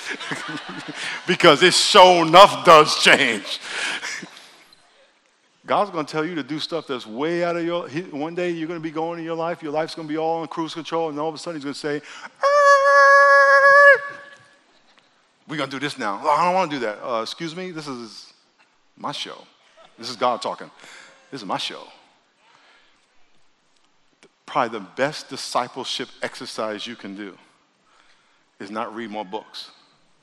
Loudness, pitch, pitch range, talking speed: -18 LUFS, 165 Hz, 145-180 Hz, 160 wpm